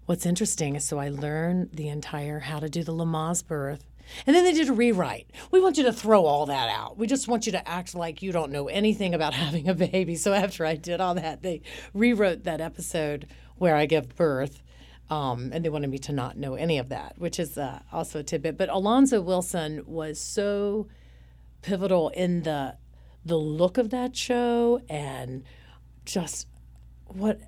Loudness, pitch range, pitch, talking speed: -26 LUFS, 150-195 Hz, 165 Hz, 195 wpm